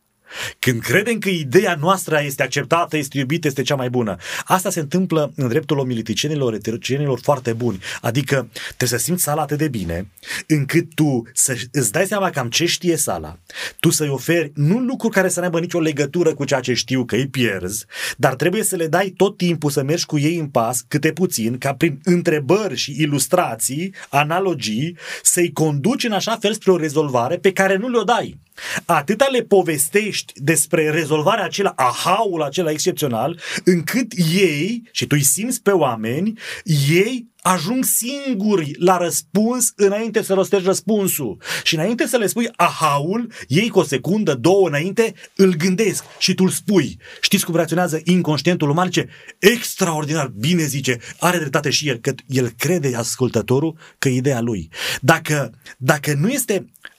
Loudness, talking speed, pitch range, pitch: -19 LUFS, 170 wpm, 140-190 Hz, 165 Hz